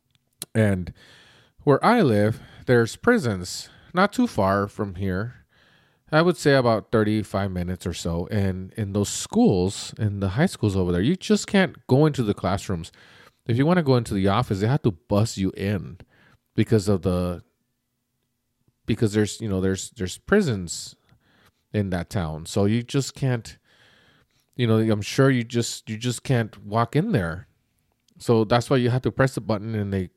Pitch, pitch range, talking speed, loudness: 110 Hz, 100-125 Hz, 180 wpm, -23 LUFS